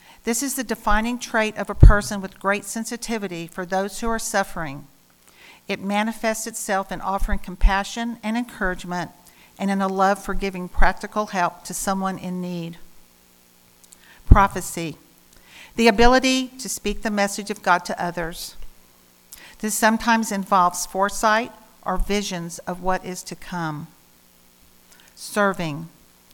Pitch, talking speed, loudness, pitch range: 190 Hz, 135 wpm, -23 LUFS, 165-215 Hz